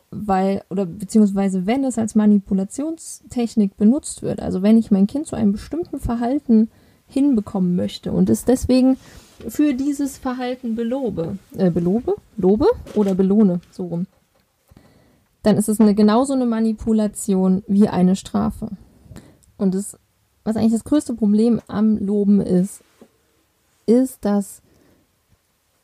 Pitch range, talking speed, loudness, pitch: 195-240 Hz, 130 wpm, -19 LUFS, 215 Hz